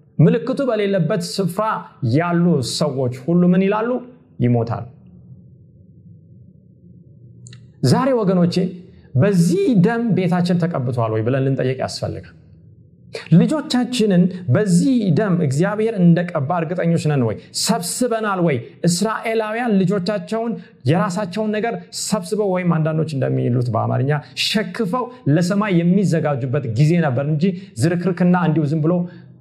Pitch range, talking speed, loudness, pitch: 150-210 Hz, 100 wpm, -18 LUFS, 175 Hz